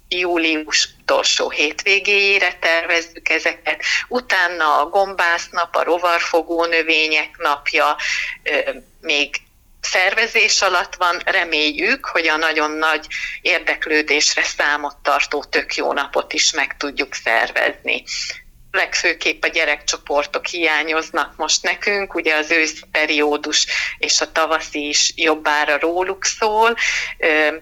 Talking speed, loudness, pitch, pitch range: 105 wpm, -17 LUFS, 160 Hz, 150-180 Hz